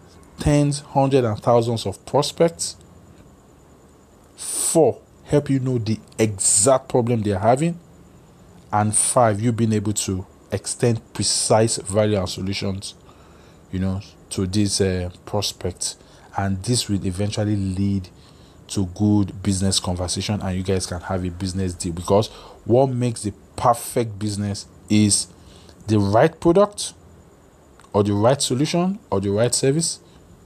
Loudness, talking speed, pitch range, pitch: -21 LUFS, 135 wpm, 95-120 Hz, 100 Hz